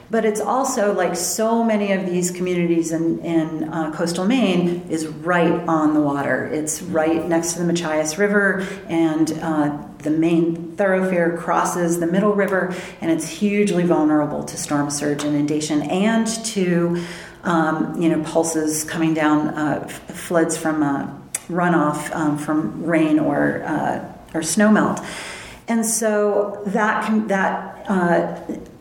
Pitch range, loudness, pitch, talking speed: 155-190 Hz, -20 LUFS, 170 Hz, 145 wpm